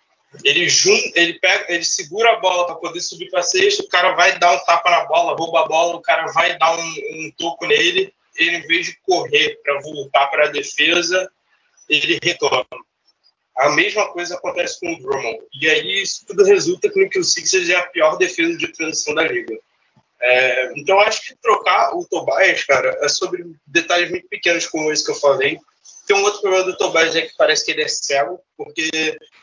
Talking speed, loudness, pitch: 210 wpm, -16 LUFS, 185 Hz